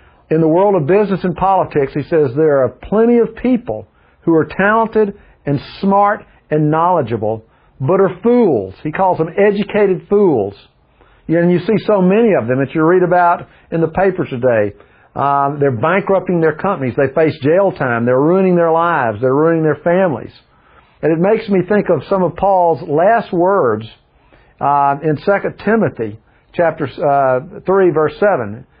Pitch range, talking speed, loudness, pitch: 140-195 Hz, 170 wpm, -14 LUFS, 170 Hz